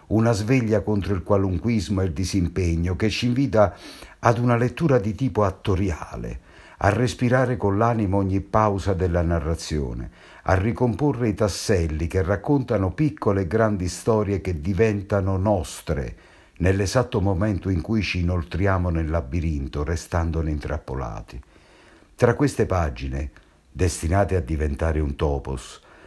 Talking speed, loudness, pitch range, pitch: 130 wpm, -23 LUFS, 85-110 Hz, 95 Hz